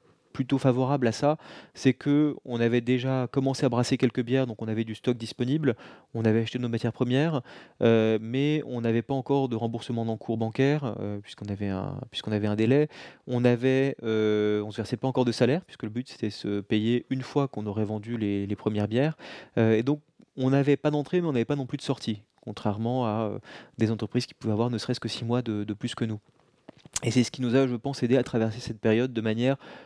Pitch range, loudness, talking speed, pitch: 110-135 Hz, -27 LUFS, 235 wpm, 120 Hz